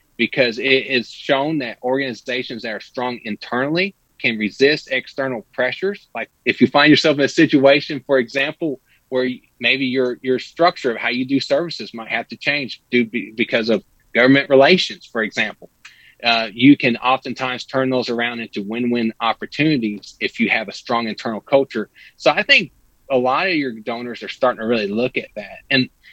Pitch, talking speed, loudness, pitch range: 125 Hz, 180 wpm, -18 LUFS, 120-140 Hz